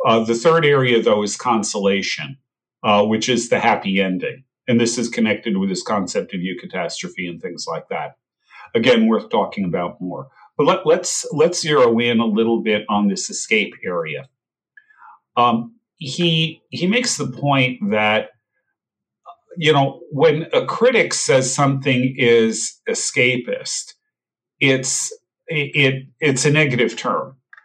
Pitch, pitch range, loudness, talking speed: 135 Hz, 115-185 Hz, -18 LUFS, 145 wpm